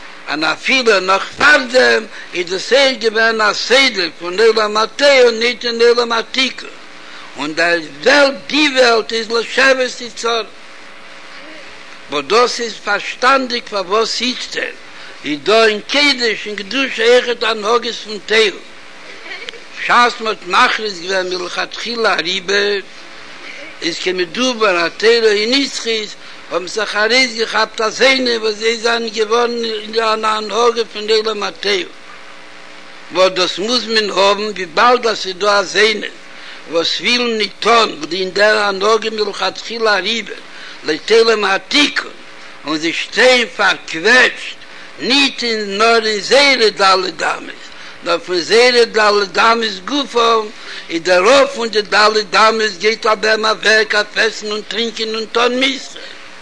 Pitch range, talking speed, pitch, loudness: 190-235 Hz, 150 wpm, 220 Hz, -14 LUFS